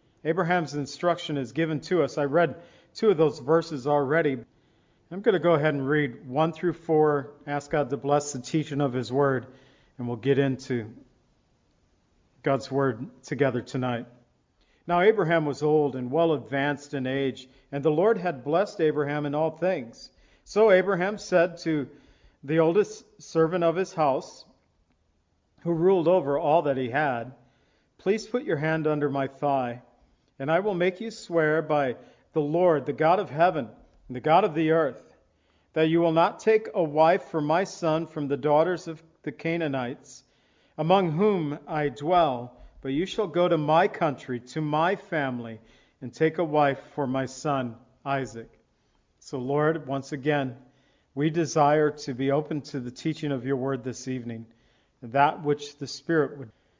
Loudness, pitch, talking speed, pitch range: -26 LUFS, 150 Hz, 170 wpm, 135-165 Hz